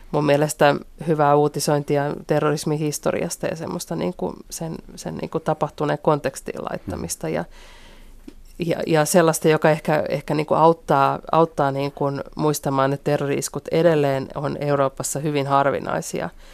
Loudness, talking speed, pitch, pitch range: -21 LUFS, 135 wpm, 150 Hz, 140-160 Hz